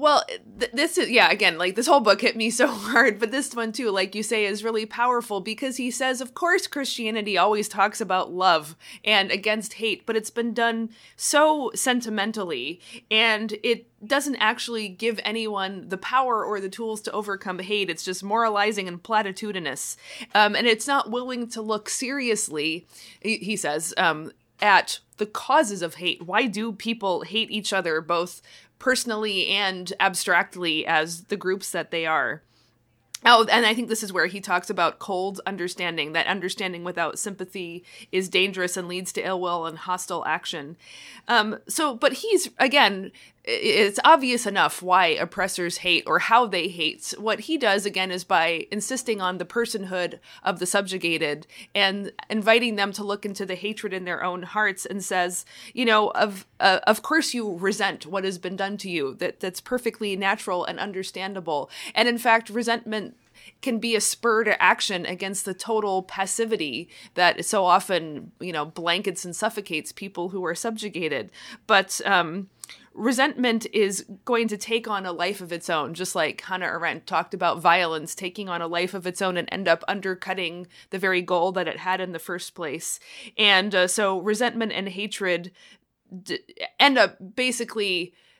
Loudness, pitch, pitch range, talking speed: -24 LUFS, 200 Hz, 180-225 Hz, 175 wpm